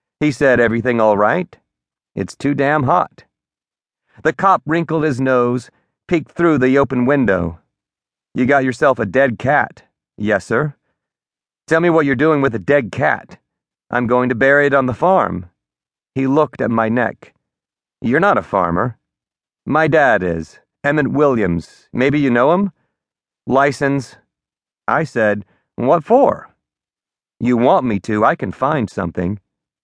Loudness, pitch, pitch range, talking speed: -16 LUFS, 125 Hz, 105-145 Hz, 150 wpm